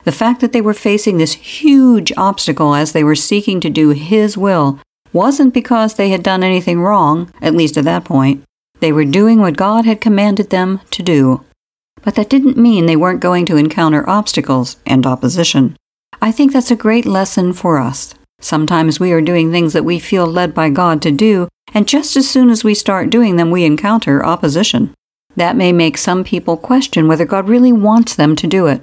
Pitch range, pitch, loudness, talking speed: 160-215 Hz, 180 Hz, -12 LUFS, 205 wpm